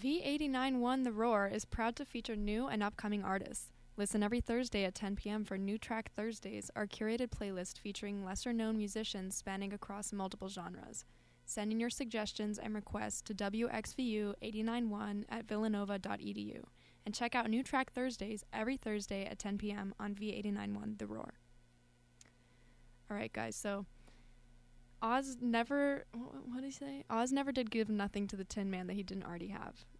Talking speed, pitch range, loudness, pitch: 160 wpm, 195-230 Hz, -40 LUFS, 210 Hz